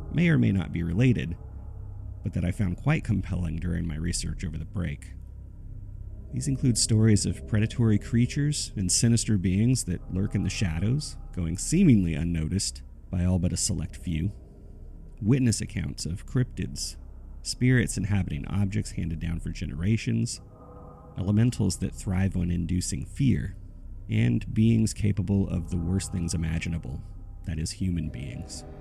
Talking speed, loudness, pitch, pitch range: 145 wpm, -27 LUFS, 95 Hz, 85-110 Hz